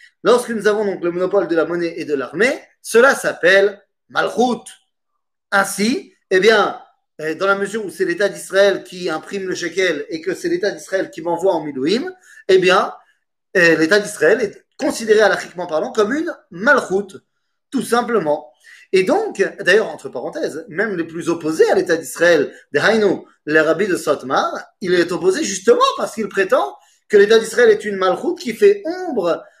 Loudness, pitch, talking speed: -17 LUFS, 210 Hz, 175 wpm